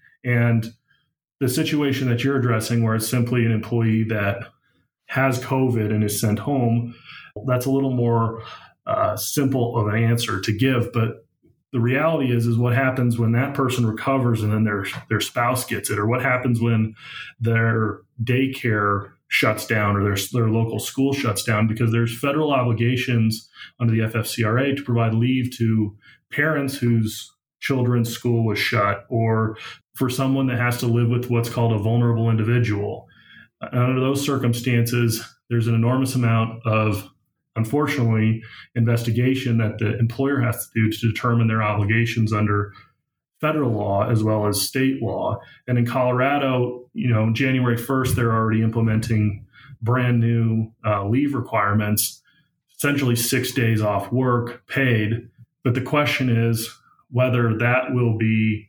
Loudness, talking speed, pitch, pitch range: -21 LUFS, 150 wpm, 120 Hz, 110-125 Hz